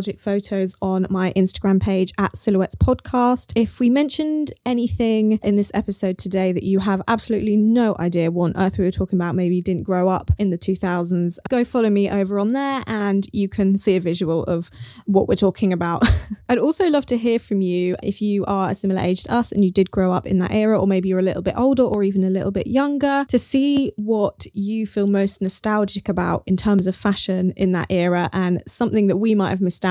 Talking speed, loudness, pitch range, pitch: 225 wpm, -20 LUFS, 185-220 Hz, 195 Hz